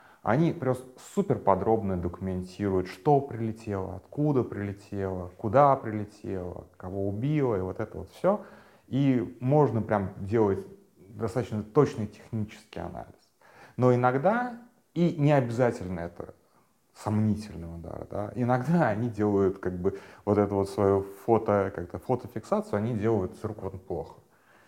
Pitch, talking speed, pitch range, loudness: 110 Hz, 125 wpm, 100-130 Hz, -28 LUFS